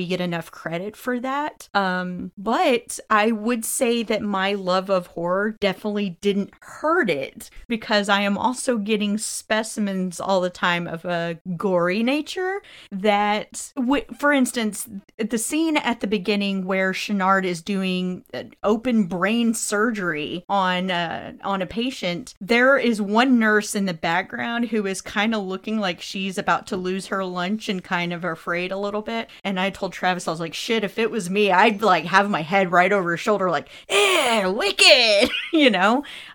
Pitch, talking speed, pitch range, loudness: 205 Hz, 170 wpm, 185-230 Hz, -22 LUFS